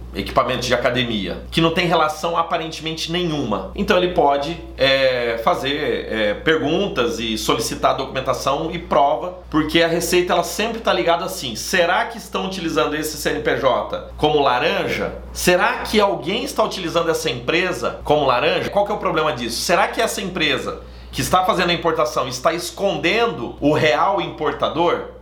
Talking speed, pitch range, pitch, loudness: 155 wpm, 150-185 Hz, 165 Hz, -19 LUFS